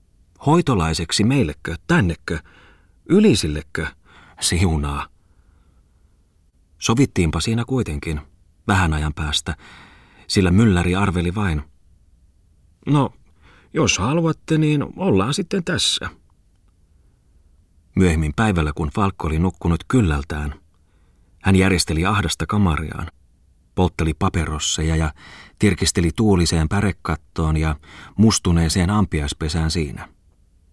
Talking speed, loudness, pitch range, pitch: 85 wpm, -20 LUFS, 80-95 Hz, 85 Hz